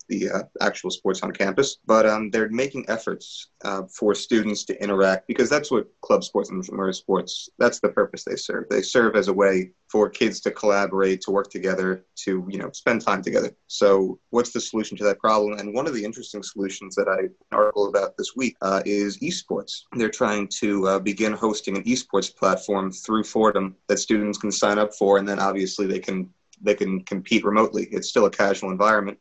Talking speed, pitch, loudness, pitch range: 205 wpm, 100 Hz, -23 LUFS, 95-110 Hz